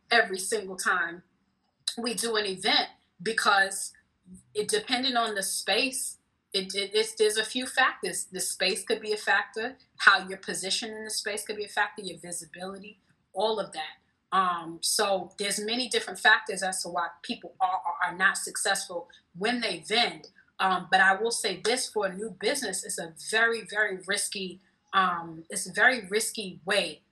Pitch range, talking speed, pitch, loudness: 185-220 Hz, 175 wpm, 200 Hz, -27 LUFS